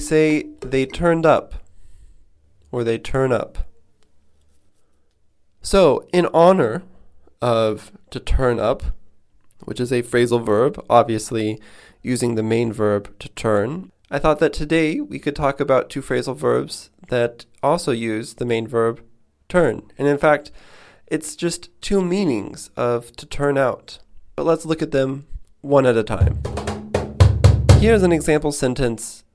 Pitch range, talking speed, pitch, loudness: 100-145 Hz, 140 wpm, 120 Hz, -19 LUFS